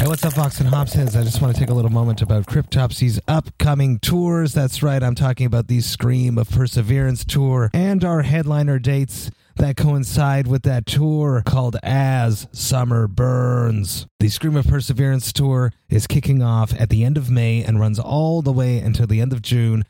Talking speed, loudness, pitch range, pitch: 195 wpm, -18 LUFS, 115-140 Hz, 130 Hz